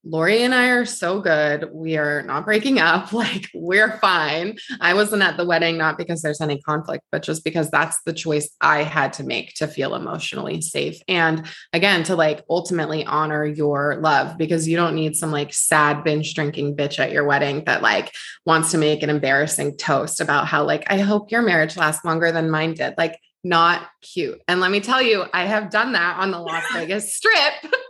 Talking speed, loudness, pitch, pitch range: 205 wpm, -20 LUFS, 165 Hz, 155-195 Hz